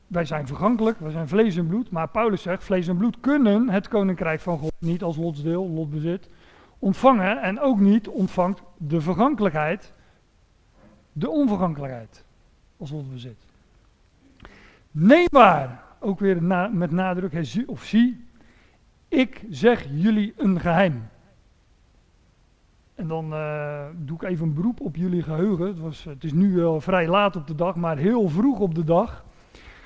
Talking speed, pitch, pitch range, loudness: 155 wpm, 180 Hz, 160-205 Hz, -22 LUFS